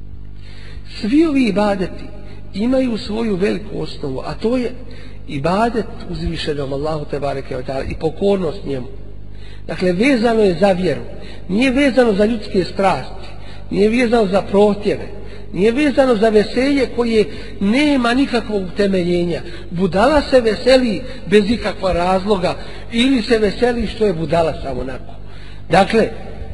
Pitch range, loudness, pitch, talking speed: 140-230 Hz, -17 LUFS, 195 Hz, 120 wpm